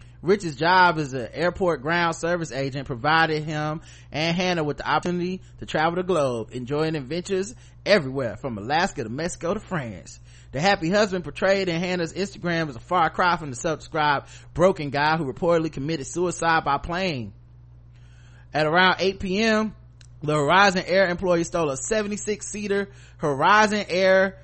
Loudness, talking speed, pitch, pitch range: -23 LUFS, 155 wpm, 165 Hz, 135-185 Hz